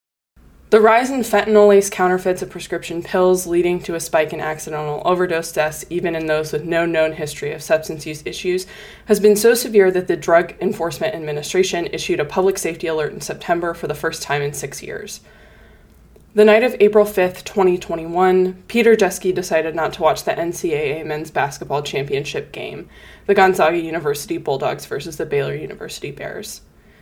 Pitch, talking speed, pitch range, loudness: 180 Hz, 170 wpm, 160-200 Hz, -18 LUFS